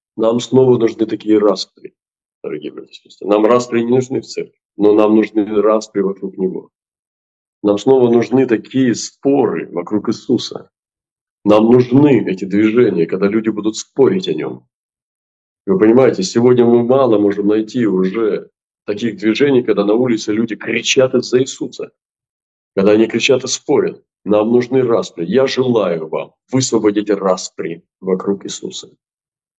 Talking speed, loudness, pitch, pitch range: 140 wpm, -14 LUFS, 110 Hz, 105-125 Hz